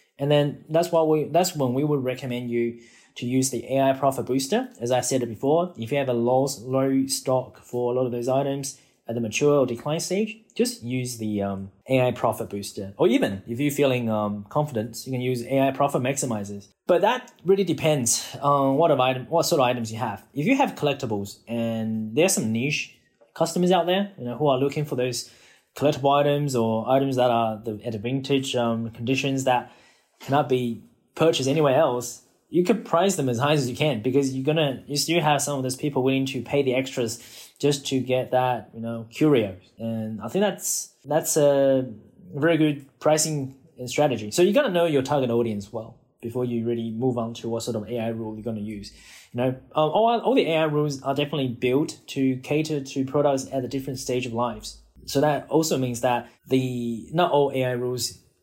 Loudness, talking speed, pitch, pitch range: -24 LUFS, 210 wpm, 130 Hz, 120-145 Hz